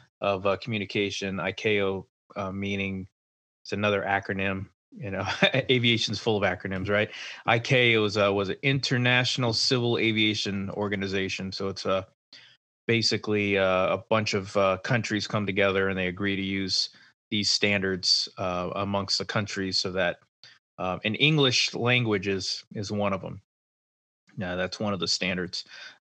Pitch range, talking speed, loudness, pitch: 95-110 Hz, 150 wpm, -26 LUFS, 100 Hz